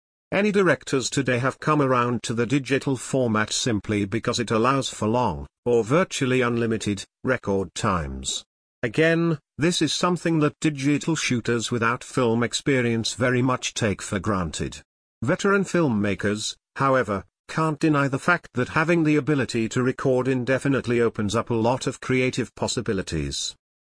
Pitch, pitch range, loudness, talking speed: 125 Hz, 110-145 Hz, -23 LUFS, 145 wpm